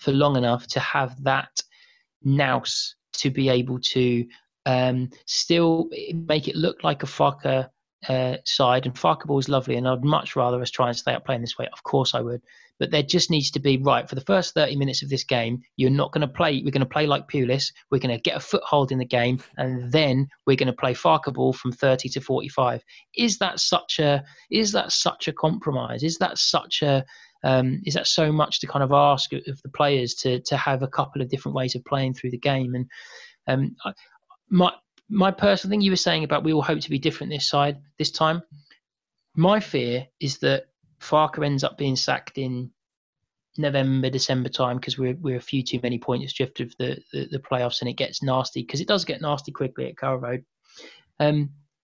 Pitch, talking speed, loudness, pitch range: 140 Hz, 220 wpm, -23 LUFS, 130-155 Hz